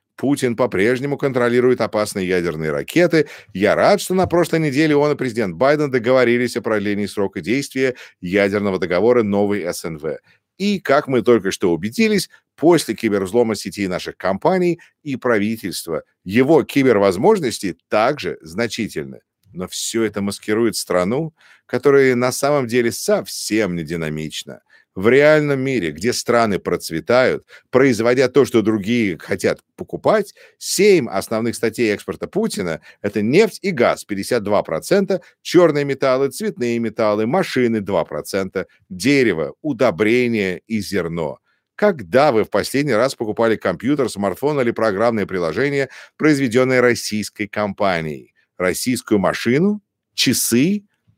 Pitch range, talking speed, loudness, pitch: 105-145 Hz, 120 wpm, -18 LUFS, 120 Hz